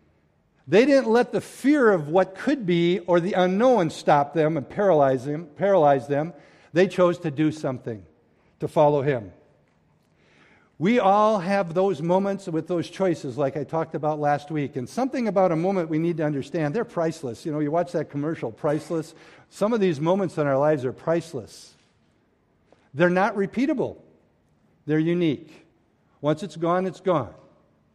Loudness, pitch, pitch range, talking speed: -23 LUFS, 165 Hz, 150-190 Hz, 165 wpm